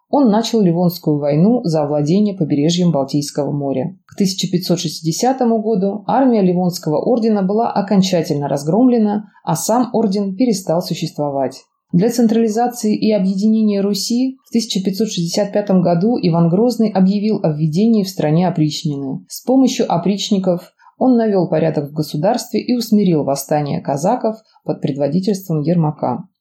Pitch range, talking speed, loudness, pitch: 160-220 Hz, 125 wpm, -16 LUFS, 190 Hz